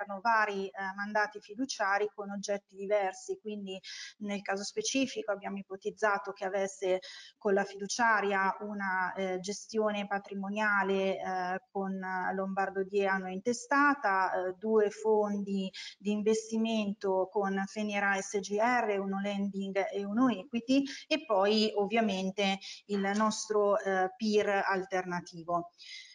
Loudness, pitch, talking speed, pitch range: -32 LUFS, 200 Hz, 110 wpm, 195-215 Hz